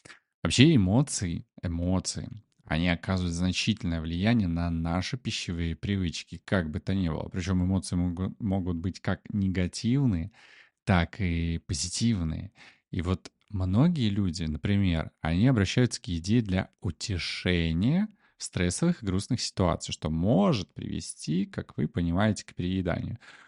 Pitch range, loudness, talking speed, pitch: 85-110 Hz, -28 LUFS, 130 wpm, 95 Hz